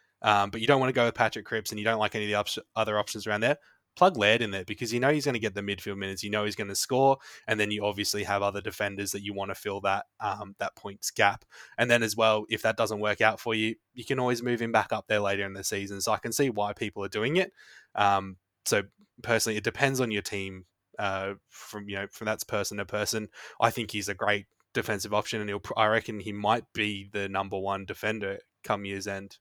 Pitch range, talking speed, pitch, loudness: 100-115 Hz, 265 wpm, 105 Hz, -28 LUFS